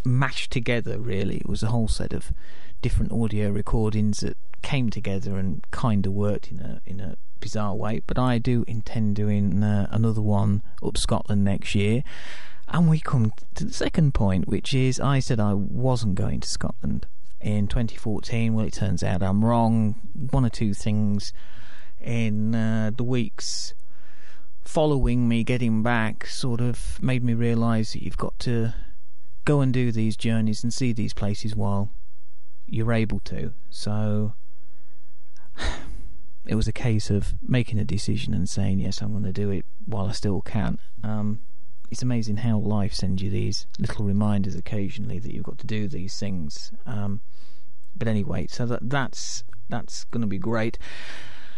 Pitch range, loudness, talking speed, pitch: 100-115 Hz, -26 LUFS, 170 wpm, 110 Hz